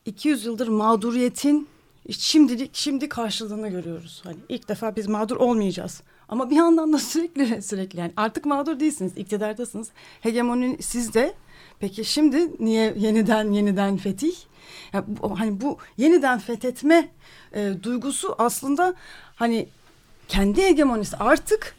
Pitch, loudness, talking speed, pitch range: 230 Hz, -23 LUFS, 120 wpm, 205-285 Hz